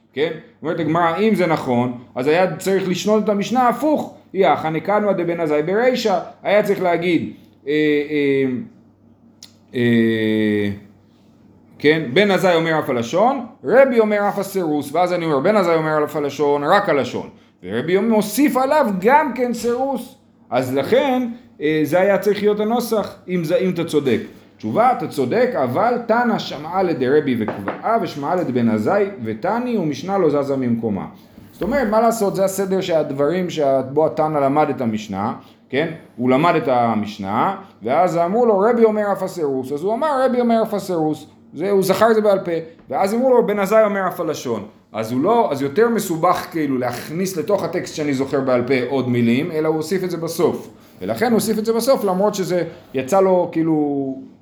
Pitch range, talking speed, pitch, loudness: 145-210 Hz, 170 wpm, 175 Hz, -18 LUFS